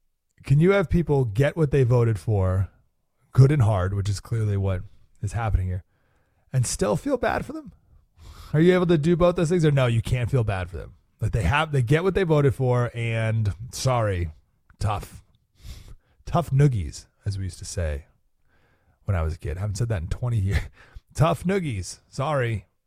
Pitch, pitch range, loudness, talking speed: 110 Hz, 90-135 Hz, -24 LUFS, 195 wpm